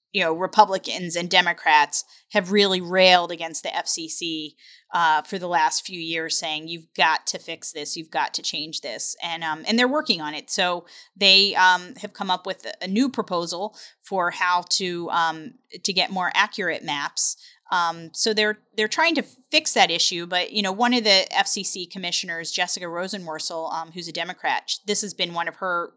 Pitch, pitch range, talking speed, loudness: 185 Hz, 170-210 Hz, 190 wpm, -22 LUFS